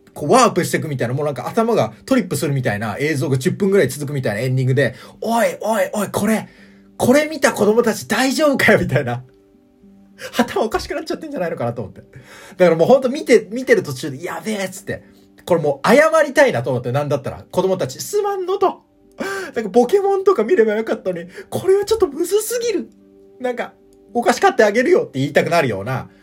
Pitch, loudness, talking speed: 200 Hz, -18 LUFS, 460 characters per minute